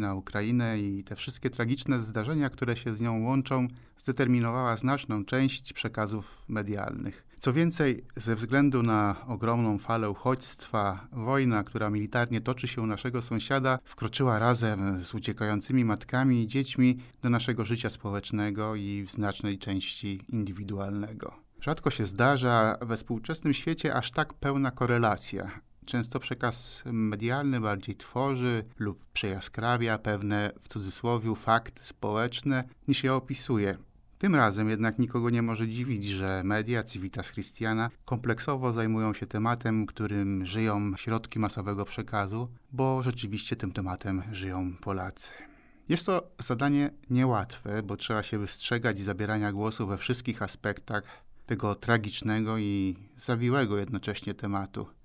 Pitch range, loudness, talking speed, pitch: 105-125 Hz, -30 LUFS, 130 wpm, 115 Hz